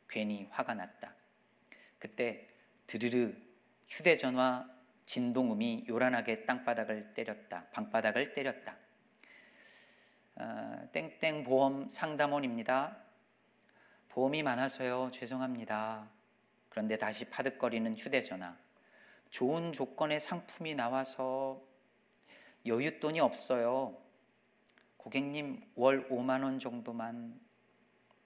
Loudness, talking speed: -36 LUFS, 215 characters per minute